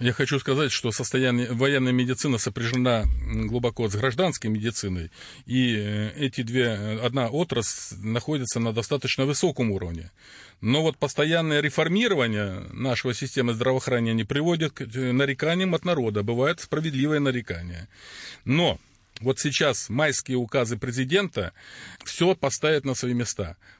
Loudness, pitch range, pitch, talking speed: -25 LUFS, 115-145 Hz, 125 Hz, 120 wpm